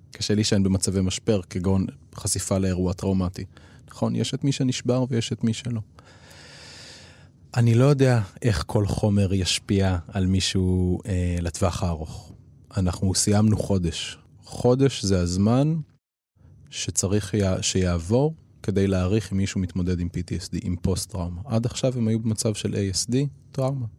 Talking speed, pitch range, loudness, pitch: 140 wpm, 95-115 Hz, -24 LUFS, 100 Hz